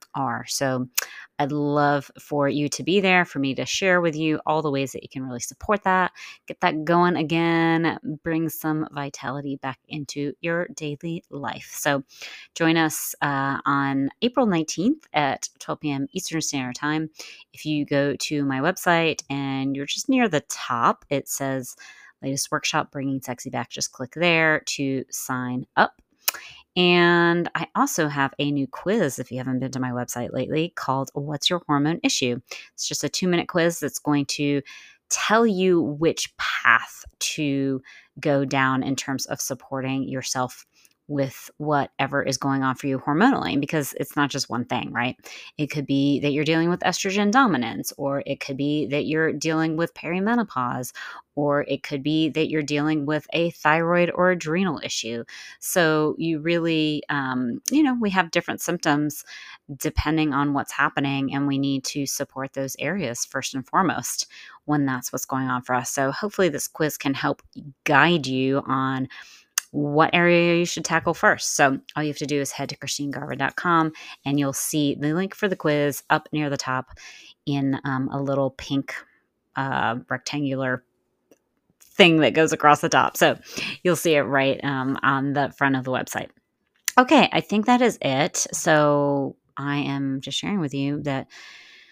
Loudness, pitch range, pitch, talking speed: -23 LUFS, 135-165 Hz, 145 Hz, 175 wpm